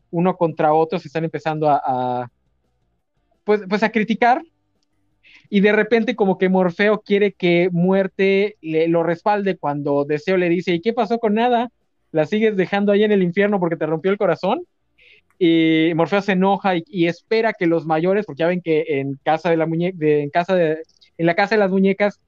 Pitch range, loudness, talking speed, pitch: 160-205 Hz, -19 LUFS, 200 wpm, 180 Hz